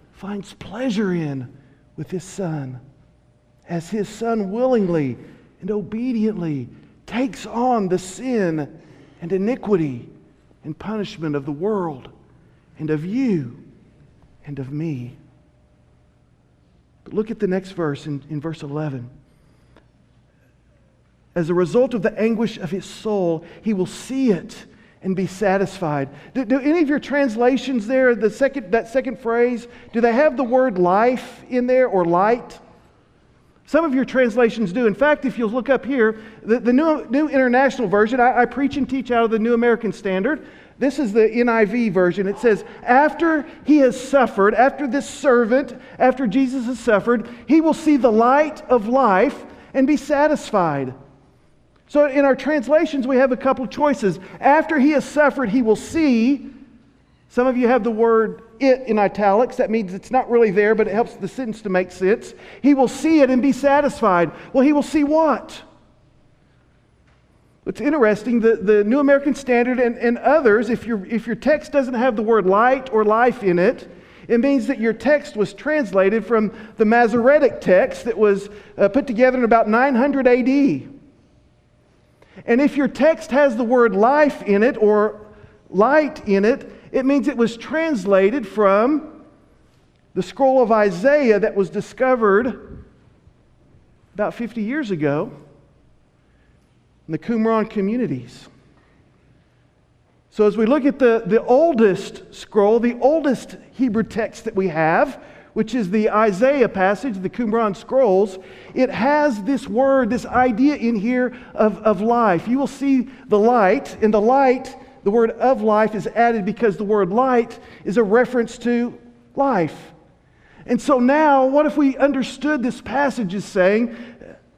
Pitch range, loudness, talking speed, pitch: 195-260 Hz, -18 LUFS, 160 wpm, 230 Hz